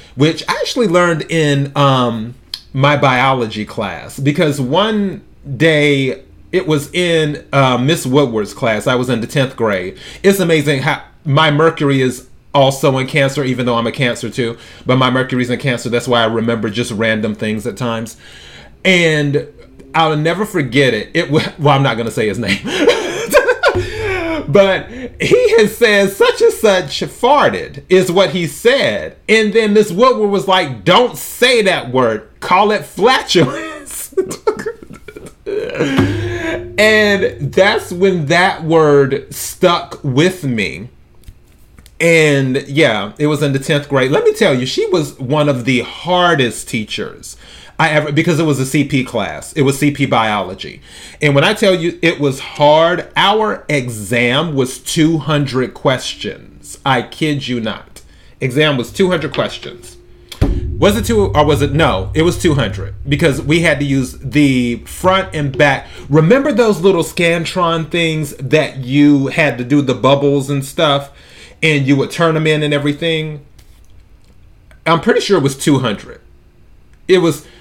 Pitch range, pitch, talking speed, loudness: 130-175 Hz, 150 Hz, 155 wpm, -14 LUFS